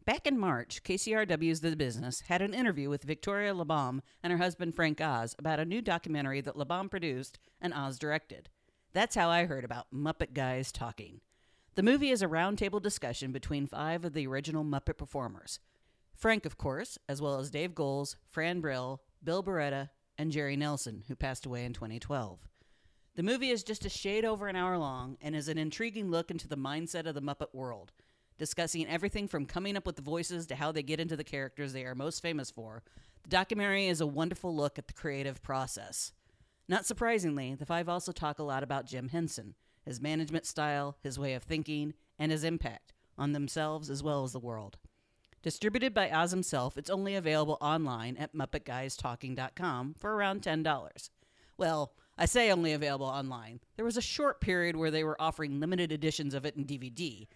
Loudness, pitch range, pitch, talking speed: -34 LUFS, 135-175 Hz, 155 Hz, 190 wpm